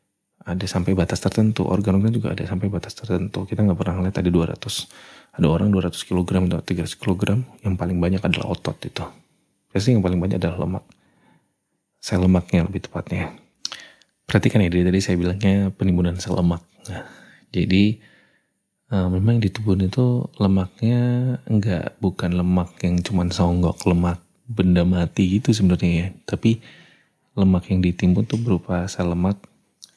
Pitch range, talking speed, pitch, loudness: 90-100 Hz, 150 wpm, 95 Hz, -21 LUFS